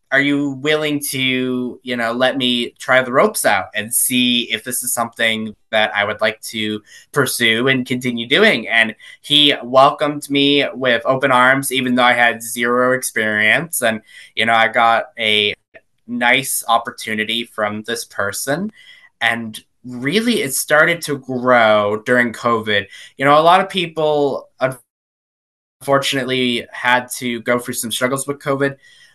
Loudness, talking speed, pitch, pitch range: -16 LUFS, 150 wpm, 125 Hz, 115-140 Hz